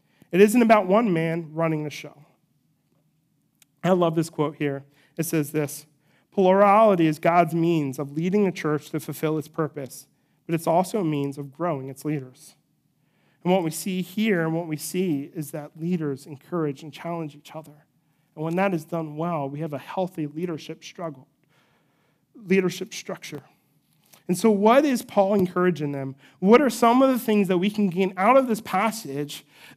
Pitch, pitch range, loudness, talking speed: 165 Hz, 150-185 Hz, -23 LUFS, 180 wpm